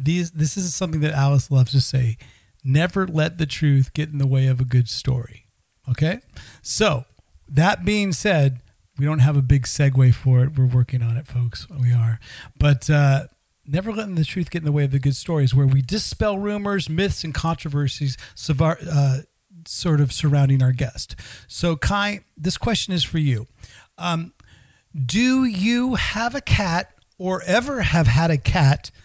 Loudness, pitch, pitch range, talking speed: -21 LUFS, 145 Hz, 130-170 Hz, 180 wpm